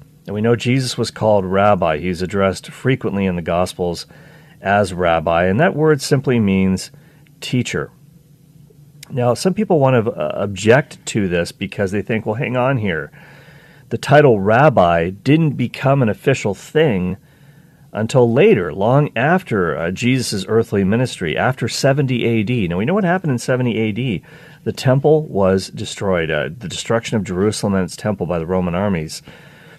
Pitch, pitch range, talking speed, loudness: 120 Hz, 100-145 Hz, 160 wpm, -17 LUFS